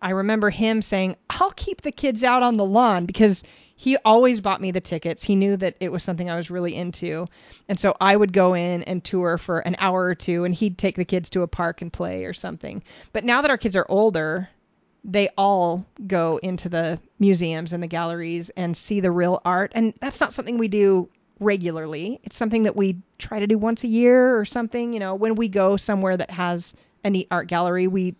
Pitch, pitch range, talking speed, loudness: 190 Hz, 175-220 Hz, 230 wpm, -22 LUFS